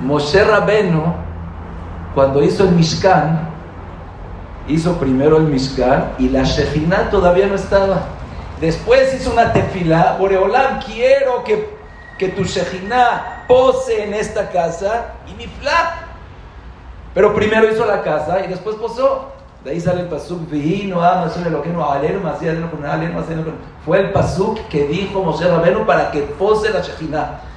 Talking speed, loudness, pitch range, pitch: 135 wpm, -16 LUFS, 150-210 Hz, 180 Hz